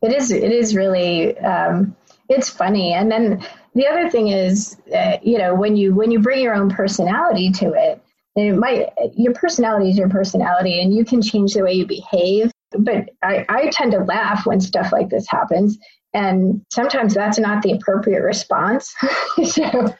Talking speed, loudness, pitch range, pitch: 185 wpm, -17 LUFS, 195-230 Hz, 210 Hz